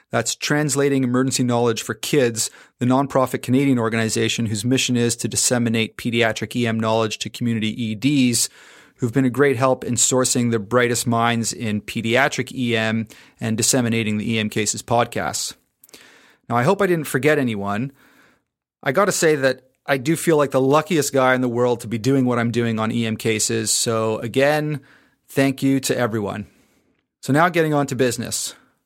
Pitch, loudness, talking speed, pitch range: 120 Hz, -20 LUFS, 175 wpm, 115-135 Hz